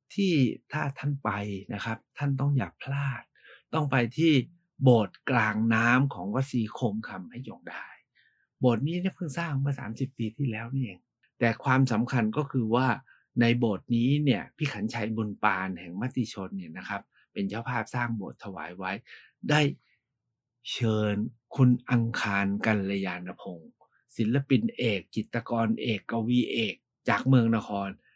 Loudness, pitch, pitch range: -28 LUFS, 120 Hz, 110-135 Hz